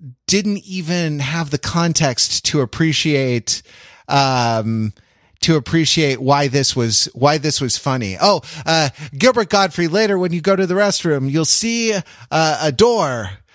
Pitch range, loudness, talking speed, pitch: 130-175 Hz, -16 LUFS, 145 wpm, 150 Hz